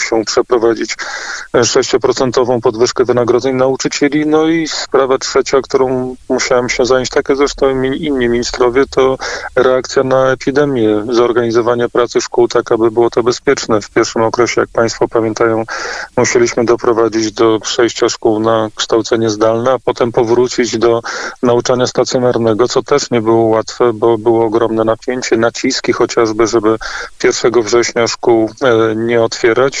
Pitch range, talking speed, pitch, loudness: 115-135 Hz, 140 wpm, 120 Hz, -13 LUFS